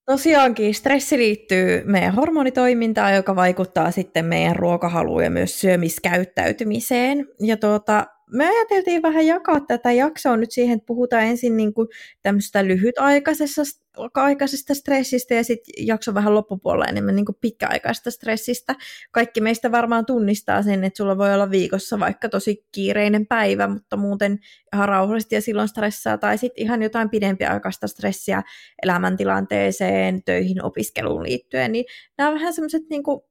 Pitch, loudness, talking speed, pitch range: 225 Hz, -20 LUFS, 135 wpm, 195-255 Hz